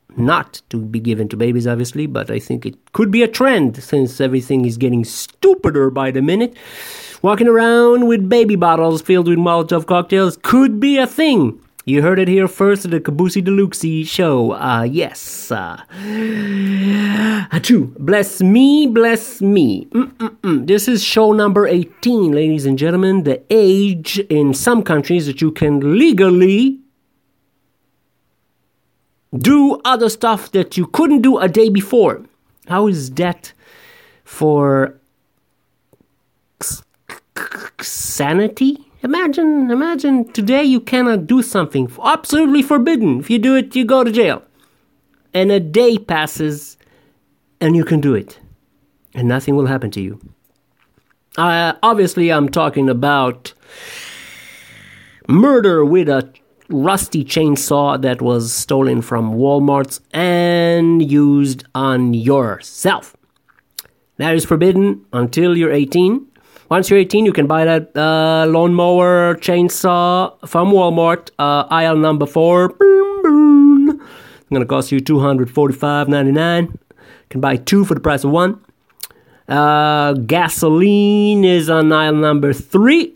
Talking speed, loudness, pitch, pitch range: 130 wpm, -14 LUFS, 175 Hz, 145-225 Hz